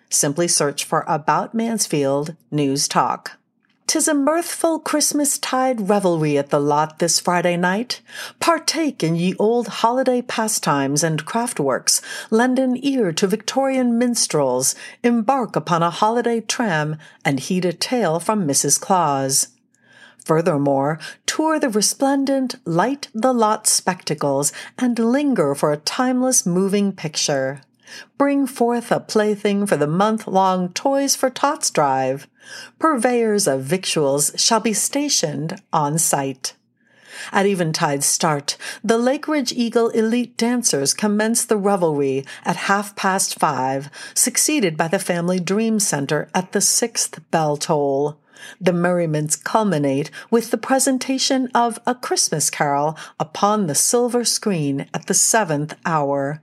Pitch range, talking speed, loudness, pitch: 155-245 Hz, 130 wpm, -19 LUFS, 200 Hz